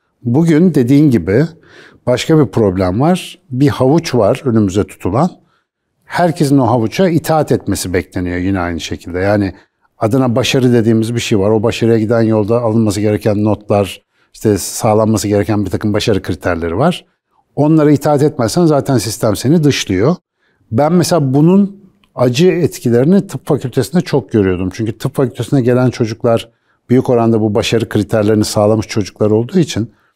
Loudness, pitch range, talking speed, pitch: -13 LUFS, 105-145 Hz, 145 wpm, 120 Hz